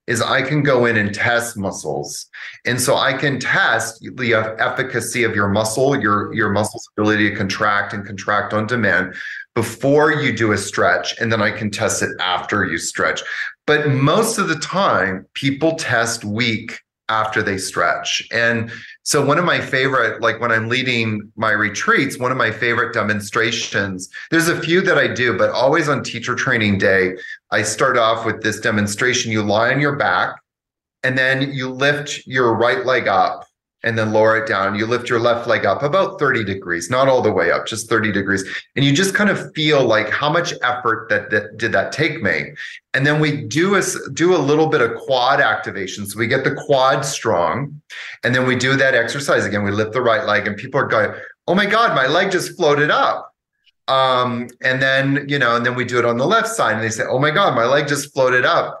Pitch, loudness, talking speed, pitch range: 120 Hz, -17 LUFS, 210 wpm, 110-140 Hz